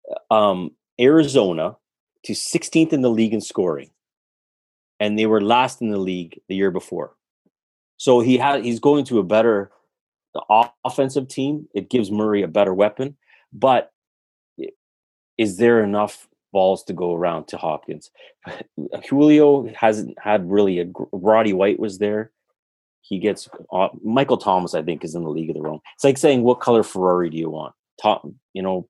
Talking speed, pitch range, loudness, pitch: 170 wpm, 100-130 Hz, -19 LUFS, 110 Hz